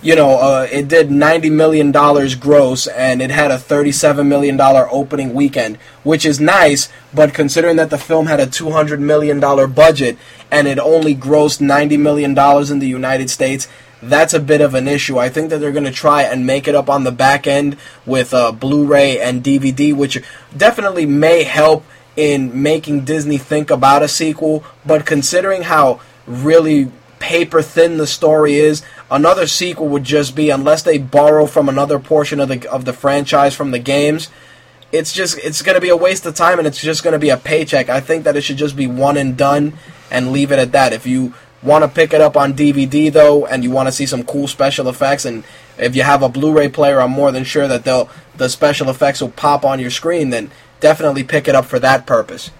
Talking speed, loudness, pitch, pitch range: 210 wpm, -13 LUFS, 145 Hz, 135-155 Hz